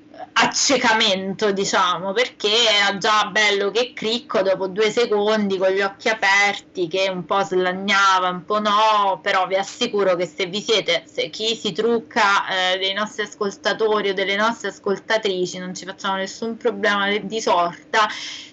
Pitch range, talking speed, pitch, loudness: 195-220 Hz, 155 wpm, 205 Hz, -19 LUFS